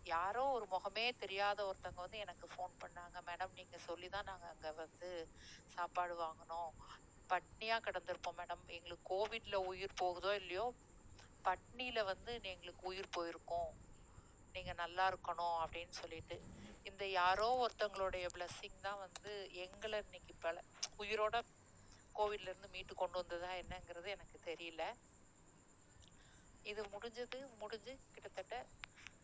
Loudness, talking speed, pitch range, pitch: -44 LUFS, 115 wpm, 175-205 Hz, 185 Hz